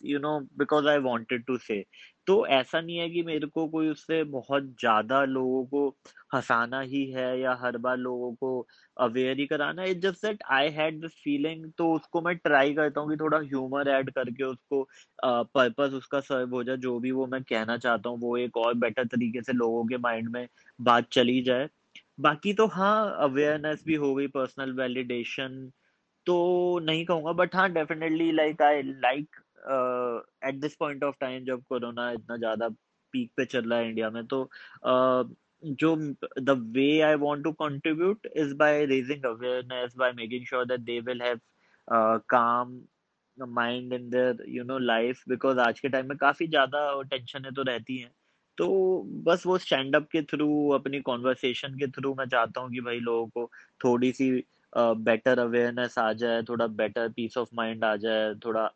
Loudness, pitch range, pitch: -28 LUFS, 125-150 Hz, 130 Hz